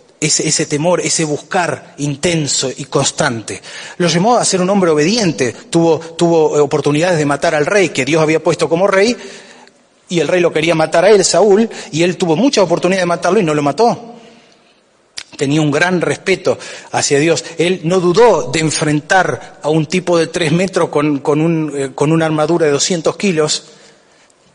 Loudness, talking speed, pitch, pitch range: -13 LUFS, 185 wpm, 165 Hz, 150-185 Hz